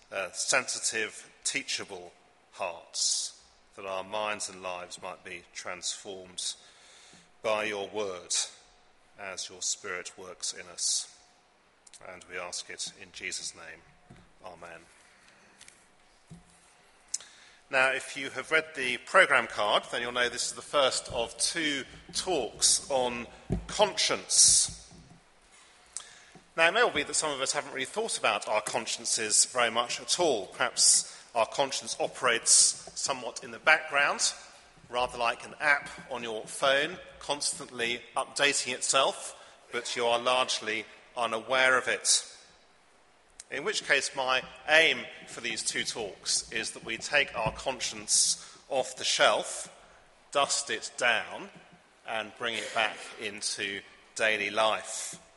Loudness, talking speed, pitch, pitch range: -28 LUFS, 130 wpm, 130 Hz, 110-140 Hz